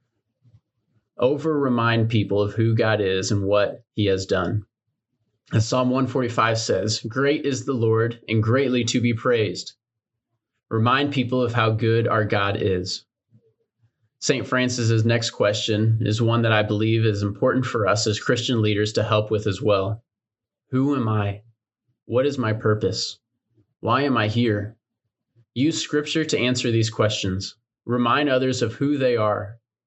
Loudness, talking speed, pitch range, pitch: -22 LUFS, 155 wpm, 110-125 Hz, 115 Hz